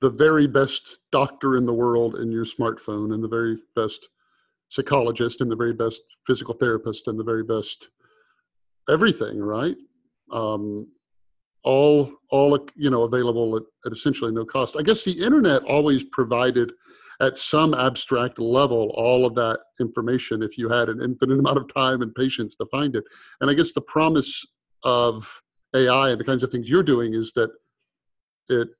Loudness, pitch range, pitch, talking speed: -22 LUFS, 115-135 Hz, 120 Hz, 170 wpm